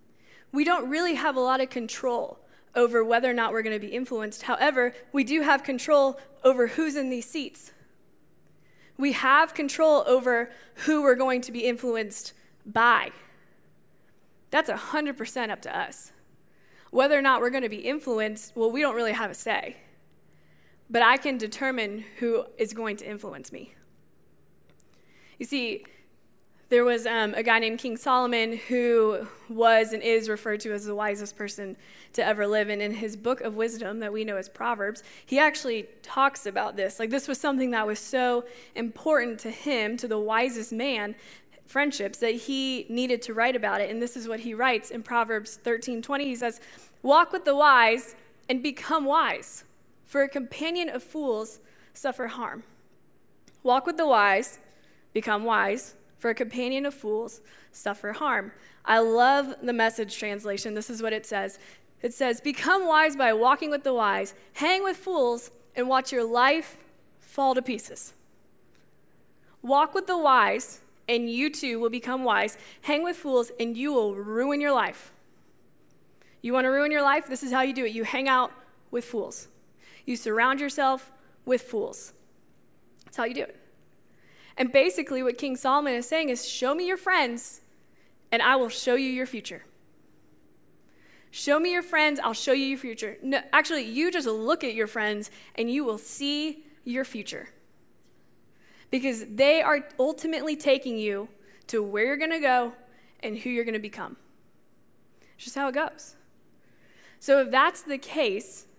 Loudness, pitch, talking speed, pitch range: -26 LUFS, 245 Hz, 170 wpm, 225-275 Hz